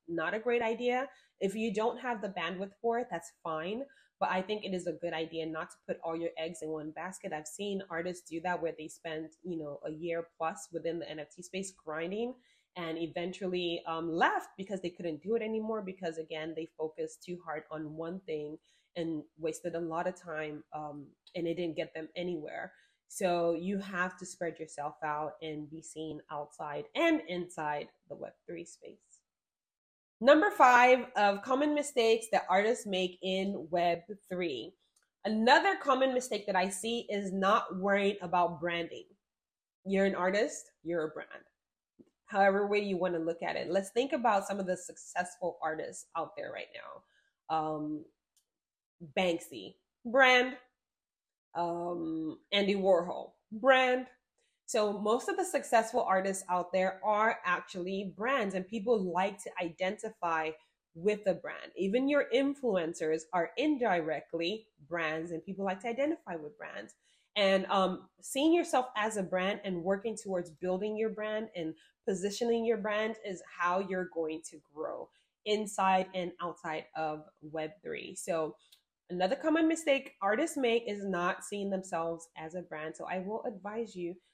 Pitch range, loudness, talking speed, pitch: 165-215 Hz, -33 LUFS, 165 wpm, 185 Hz